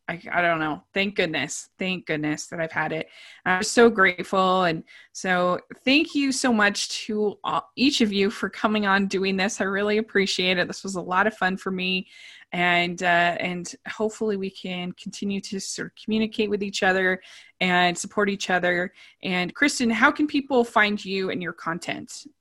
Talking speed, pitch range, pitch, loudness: 190 wpm, 180-215 Hz, 195 Hz, -23 LUFS